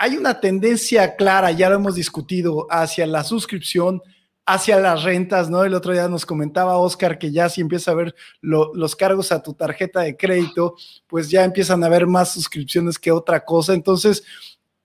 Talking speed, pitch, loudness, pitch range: 185 wpm, 180 Hz, -18 LUFS, 165-190 Hz